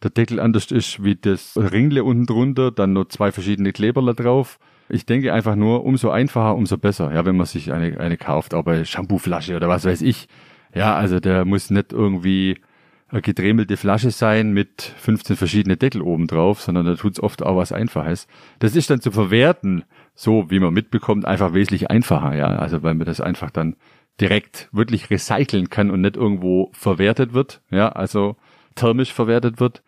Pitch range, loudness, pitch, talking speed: 95-120 Hz, -19 LUFS, 105 Hz, 190 wpm